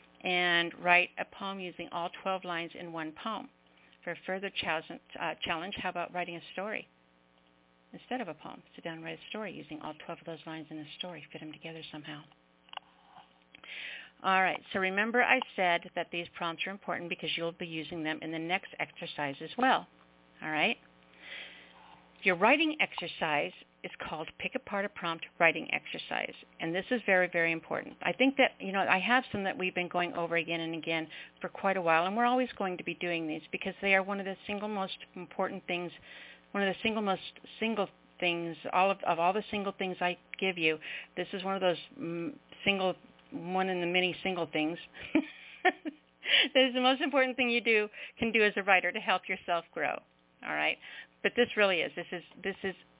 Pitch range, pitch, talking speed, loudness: 160-195 Hz, 180 Hz, 205 wpm, -31 LUFS